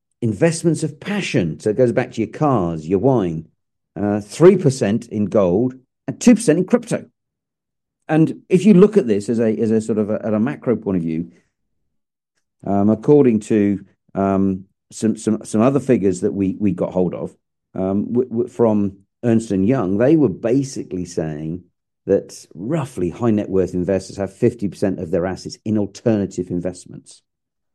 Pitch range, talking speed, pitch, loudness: 95-125 Hz, 175 wpm, 105 Hz, -18 LUFS